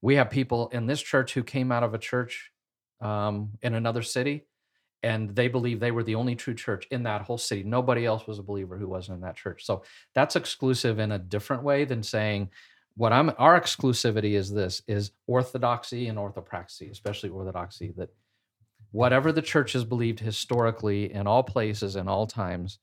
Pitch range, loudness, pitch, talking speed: 105-125 Hz, -27 LUFS, 115 Hz, 190 wpm